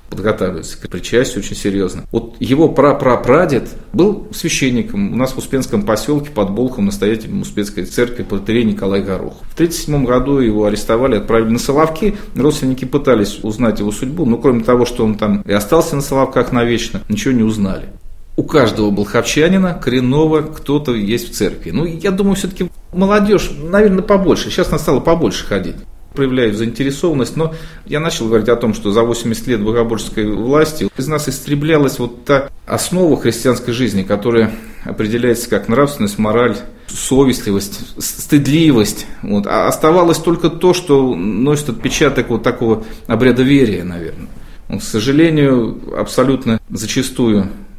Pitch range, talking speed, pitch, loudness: 110-150 Hz, 145 wpm, 125 Hz, -15 LUFS